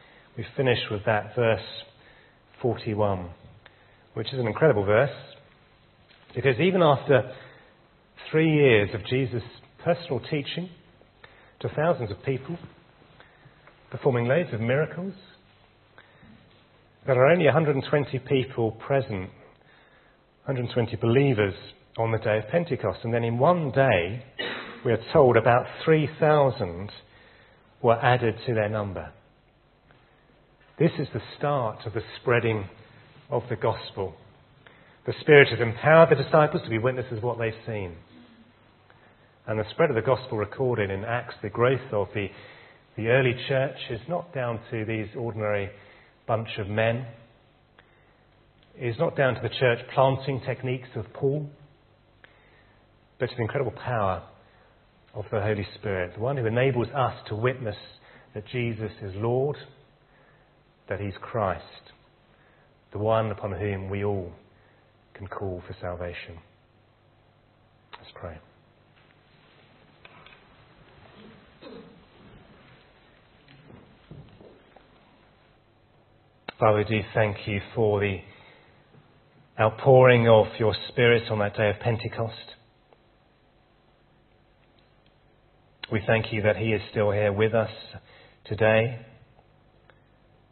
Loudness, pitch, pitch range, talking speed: -25 LUFS, 115 Hz, 105-130 Hz, 115 wpm